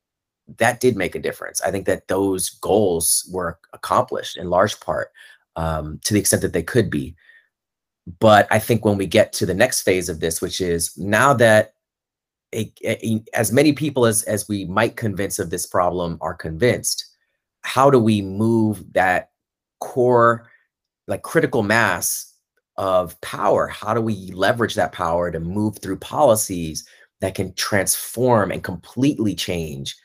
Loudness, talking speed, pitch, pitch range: -20 LUFS, 160 wpm, 100 Hz, 85-110 Hz